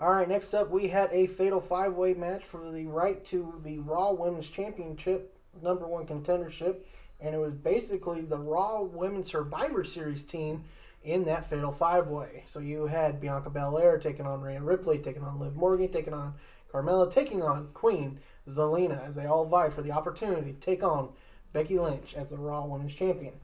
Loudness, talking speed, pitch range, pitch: -31 LUFS, 185 wpm, 150-185 Hz, 165 Hz